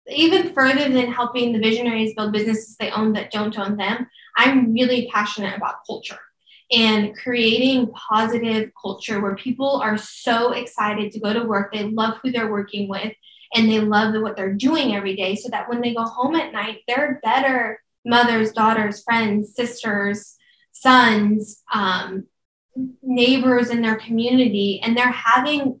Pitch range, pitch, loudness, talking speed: 210-245 Hz, 225 Hz, -20 LUFS, 160 wpm